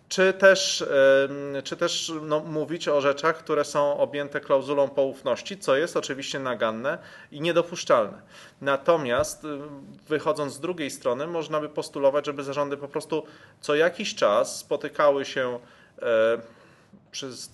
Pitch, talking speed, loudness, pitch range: 150 Hz, 130 wpm, -25 LUFS, 140-170 Hz